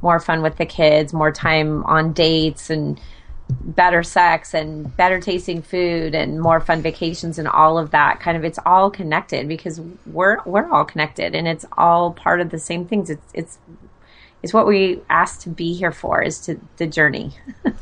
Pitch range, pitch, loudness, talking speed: 155-175 Hz, 165 Hz, -18 LUFS, 190 wpm